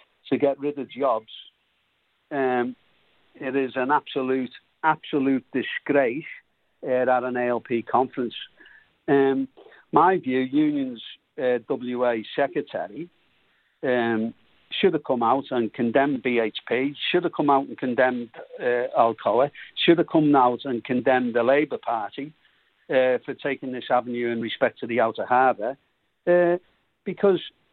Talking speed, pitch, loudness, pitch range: 135 wpm, 130 Hz, -24 LUFS, 125-145 Hz